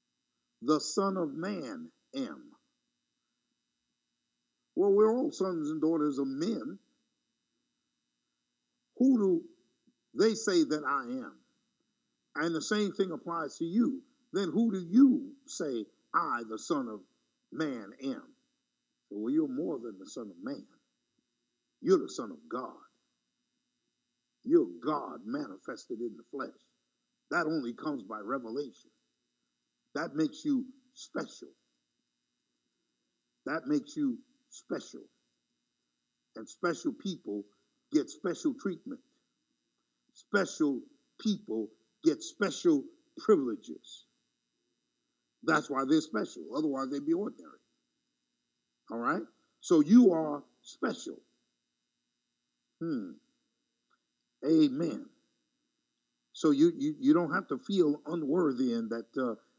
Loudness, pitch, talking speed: -32 LUFS, 255 Hz, 110 wpm